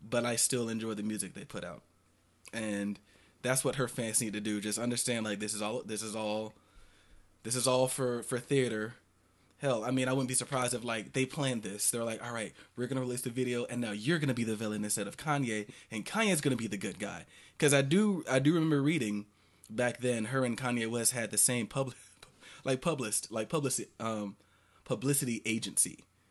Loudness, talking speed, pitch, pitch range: -32 LUFS, 210 wpm, 115 Hz, 105-130 Hz